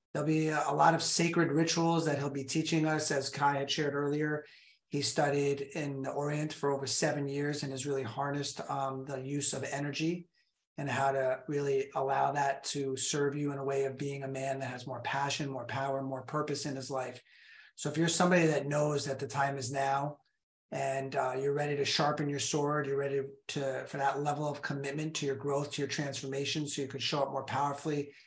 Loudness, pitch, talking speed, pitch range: -32 LUFS, 140 Hz, 215 wpm, 135-150 Hz